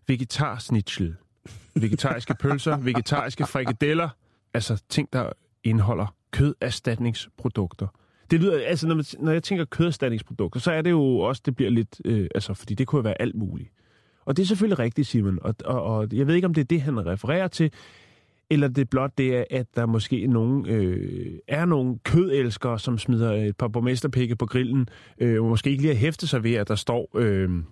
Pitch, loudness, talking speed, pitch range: 125 Hz, -25 LUFS, 190 wpm, 110-145 Hz